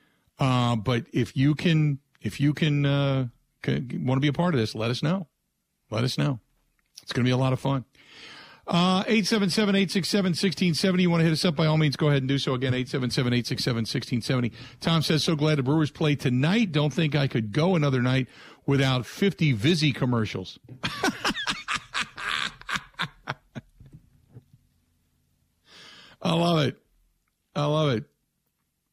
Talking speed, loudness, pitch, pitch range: 180 wpm, -25 LUFS, 140 Hz, 125-160 Hz